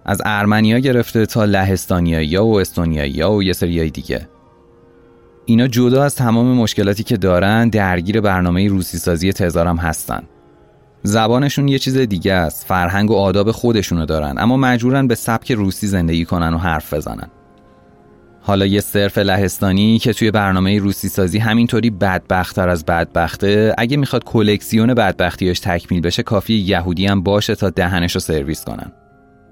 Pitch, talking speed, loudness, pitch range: 100 Hz, 145 wpm, -16 LUFS, 85-110 Hz